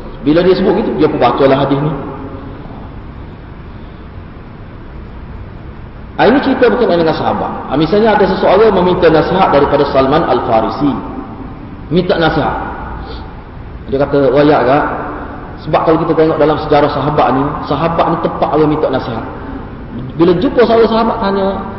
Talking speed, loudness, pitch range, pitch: 145 wpm, -12 LUFS, 135-175 Hz, 150 Hz